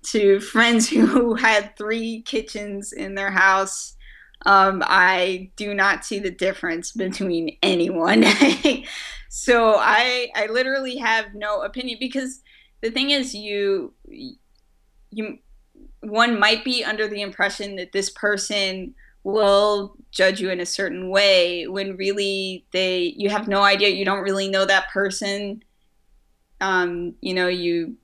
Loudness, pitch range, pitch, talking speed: -20 LUFS, 190-225 Hz, 200 Hz, 135 wpm